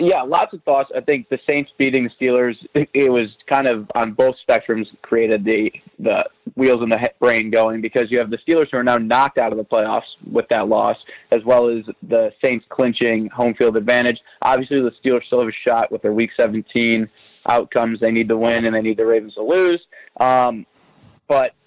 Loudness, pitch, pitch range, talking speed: -18 LUFS, 120 Hz, 115-130 Hz, 210 wpm